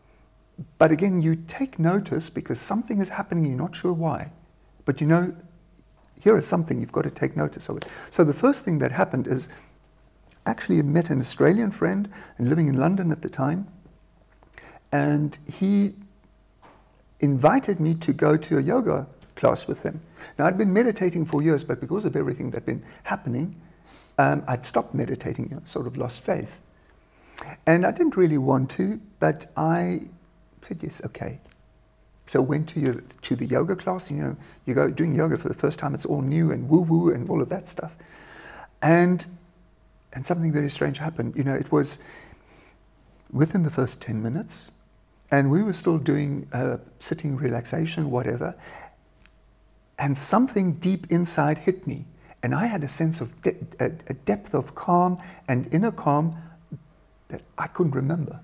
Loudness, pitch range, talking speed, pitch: -24 LUFS, 140-175 Hz, 175 wpm, 160 Hz